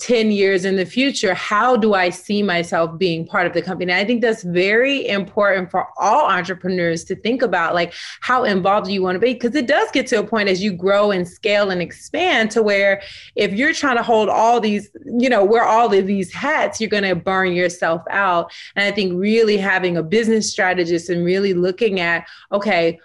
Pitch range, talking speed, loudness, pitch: 185-225 Hz, 215 wpm, -17 LUFS, 200 Hz